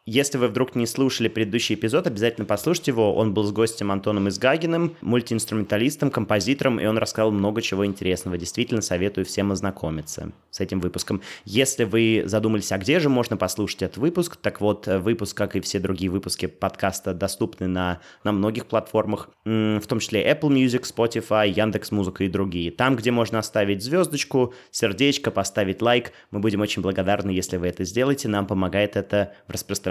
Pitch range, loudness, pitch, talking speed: 100-120 Hz, -23 LUFS, 105 Hz, 170 wpm